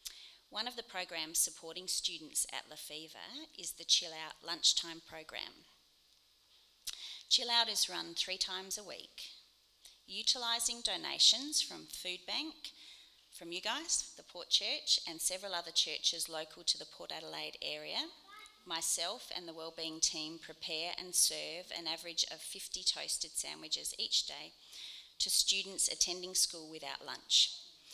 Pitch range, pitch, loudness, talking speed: 160-210 Hz, 175 Hz, -34 LUFS, 140 wpm